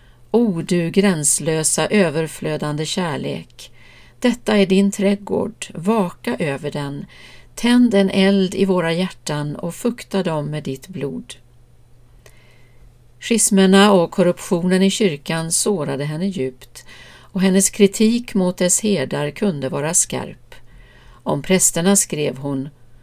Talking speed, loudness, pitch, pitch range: 115 wpm, -18 LUFS, 175 Hz, 140-195 Hz